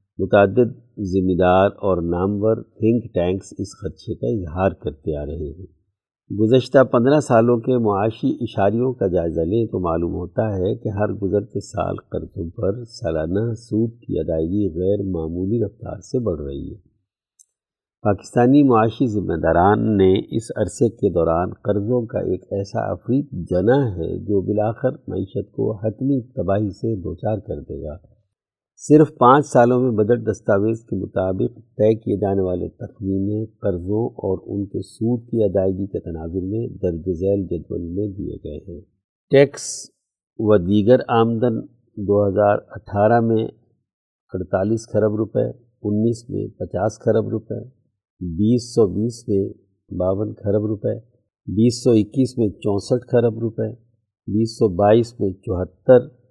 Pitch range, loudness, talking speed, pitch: 95-115 Hz, -20 LUFS, 145 wpm, 105 Hz